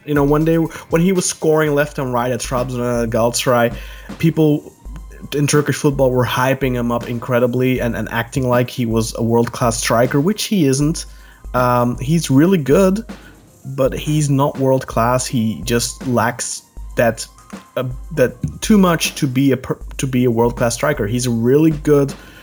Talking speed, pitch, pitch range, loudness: 180 wpm, 130 Hz, 120-150 Hz, -17 LUFS